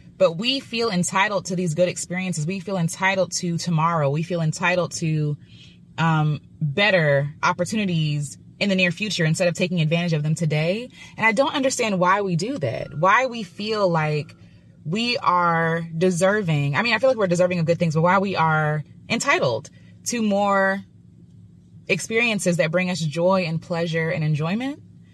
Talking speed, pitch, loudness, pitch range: 170 wpm, 180 Hz, -21 LUFS, 160-195 Hz